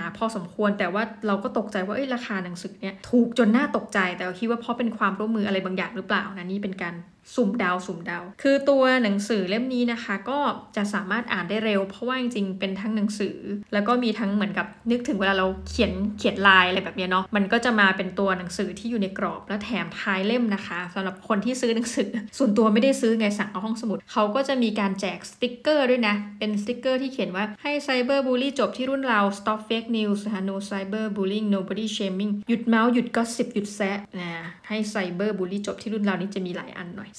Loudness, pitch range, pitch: -25 LUFS, 195-235 Hz, 210 Hz